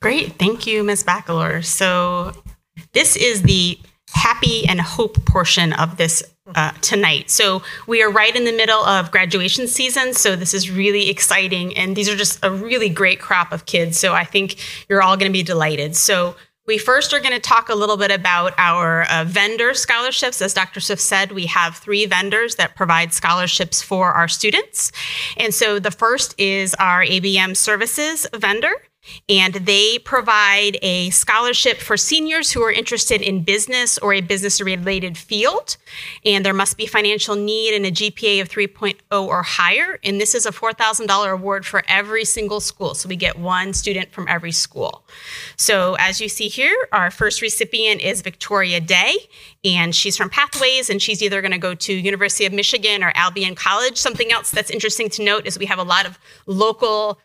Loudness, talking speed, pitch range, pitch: -16 LUFS, 185 wpm, 185-220 Hz, 200 Hz